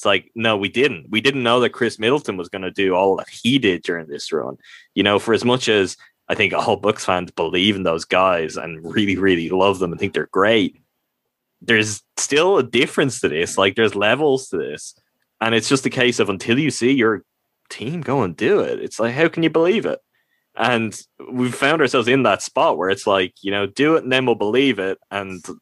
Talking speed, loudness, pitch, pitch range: 230 wpm, -19 LUFS, 110 Hz, 95-130 Hz